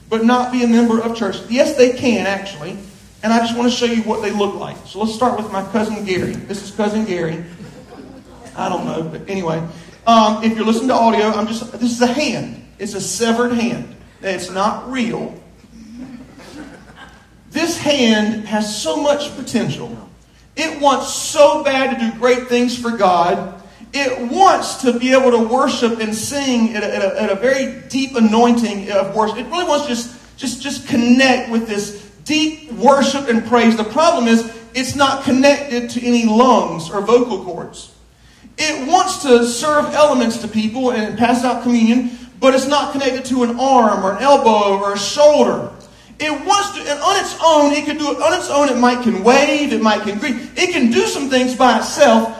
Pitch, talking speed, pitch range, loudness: 240 Hz, 195 wpm, 215-270 Hz, -16 LUFS